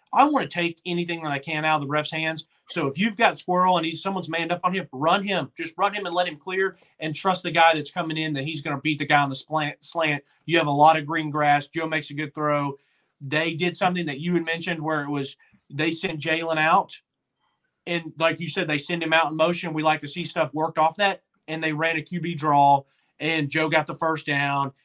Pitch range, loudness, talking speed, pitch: 150-175 Hz, -24 LUFS, 260 wpm, 160 Hz